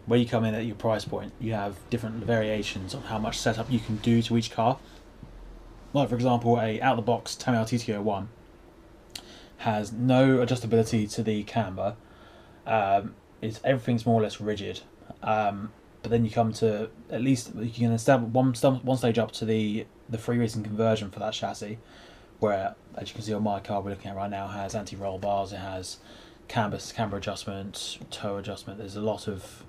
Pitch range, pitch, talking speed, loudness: 100-115 Hz, 110 Hz, 200 wpm, -28 LUFS